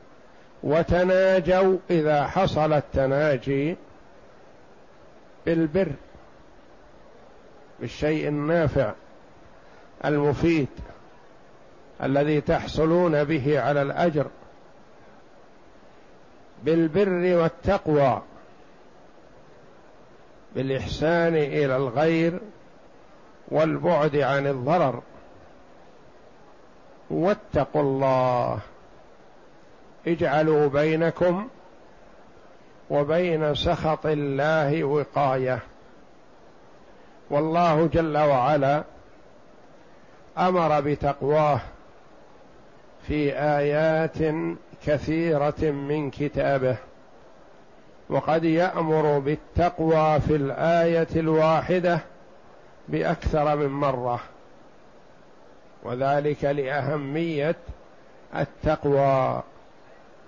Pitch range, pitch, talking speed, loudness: 145-165 Hz, 150 Hz, 50 wpm, -23 LUFS